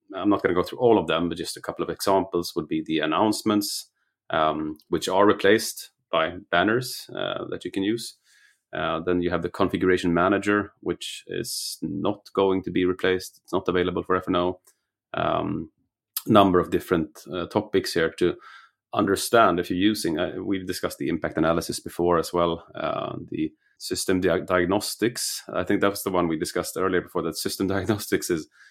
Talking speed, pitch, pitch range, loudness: 185 wpm, 95 Hz, 90-105 Hz, -25 LUFS